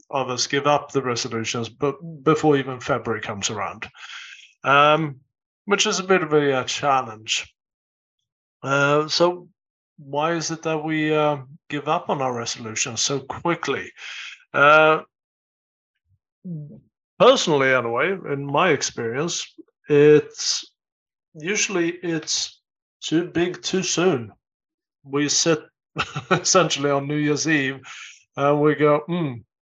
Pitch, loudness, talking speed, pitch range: 150 Hz, -21 LUFS, 115 wpm, 130-165 Hz